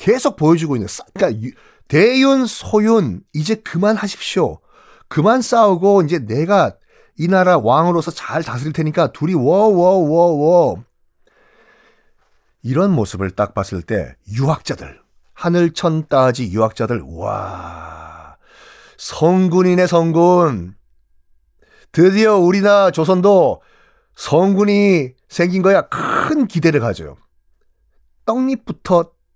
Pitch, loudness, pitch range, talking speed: 165 Hz, -15 LUFS, 120-190 Hz, 230 characters per minute